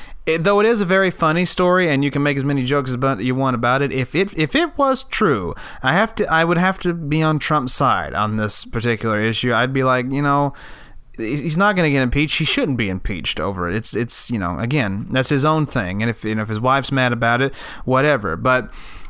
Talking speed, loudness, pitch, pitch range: 250 wpm, -18 LUFS, 135 Hz, 120-160 Hz